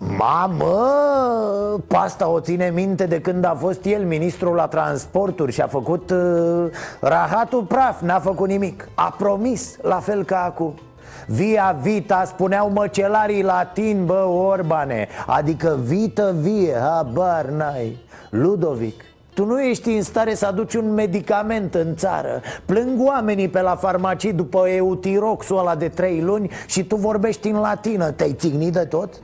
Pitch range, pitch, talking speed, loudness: 170-210 Hz, 190 Hz, 150 wpm, -20 LUFS